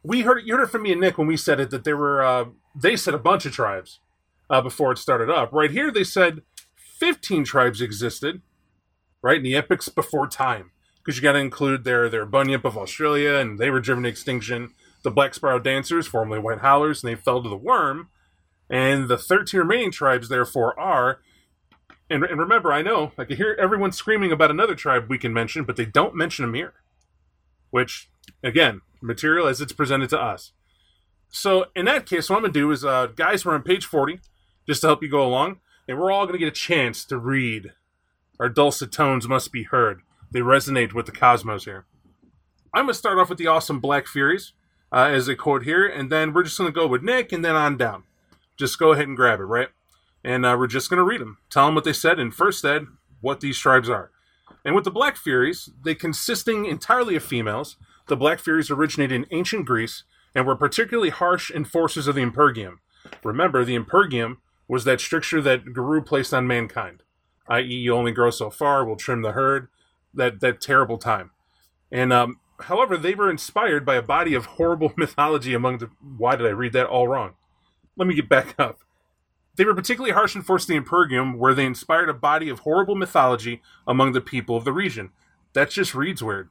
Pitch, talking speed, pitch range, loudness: 135 Hz, 210 wpm, 120-160 Hz, -21 LUFS